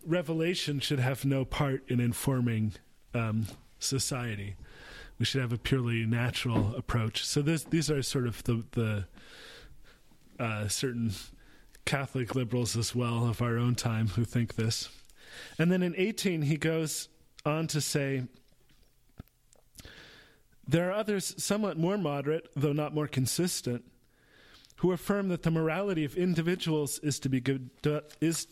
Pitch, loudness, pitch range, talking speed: 135 Hz, -31 LUFS, 120-160 Hz, 145 wpm